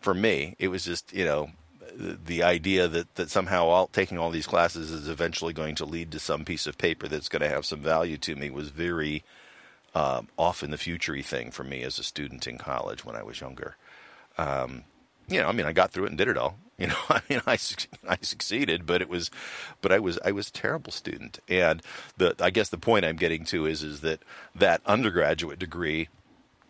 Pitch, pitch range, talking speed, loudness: 80 Hz, 75-85 Hz, 225 wpm, -28 LUFS